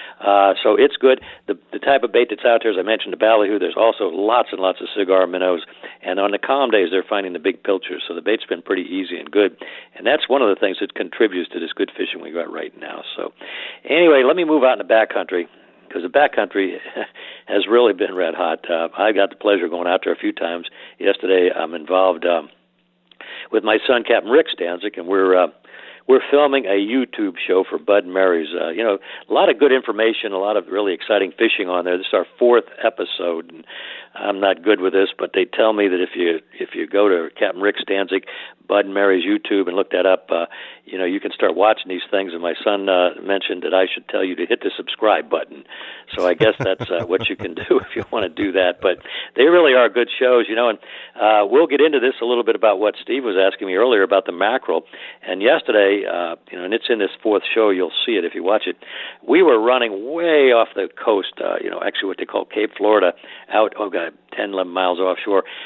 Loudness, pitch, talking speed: -18 LUFS, 120 Hz, 245 wpm